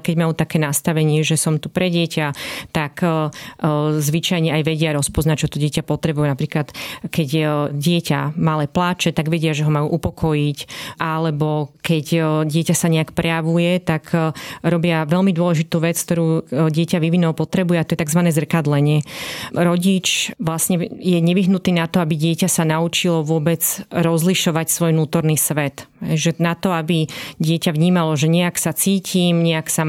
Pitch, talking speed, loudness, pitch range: 165 Hz, 150 wpm, -18 LUFS, 155-175 Hz